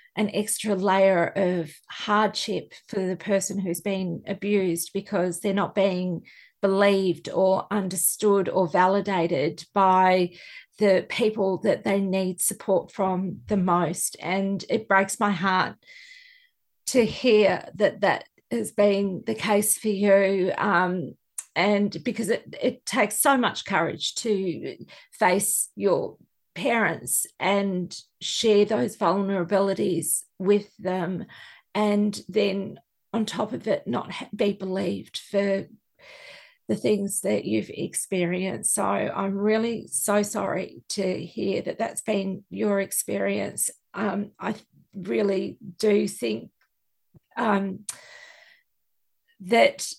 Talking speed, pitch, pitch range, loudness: 120 wpm, 195 Hz, 185-210 Hz, -25 LUFS